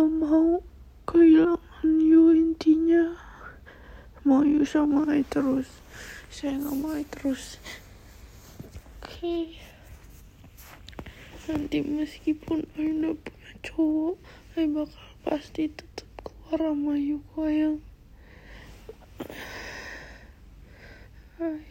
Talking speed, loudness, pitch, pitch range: 75 wpm, -25 LUFS, 315 Hz, 295-325 Hz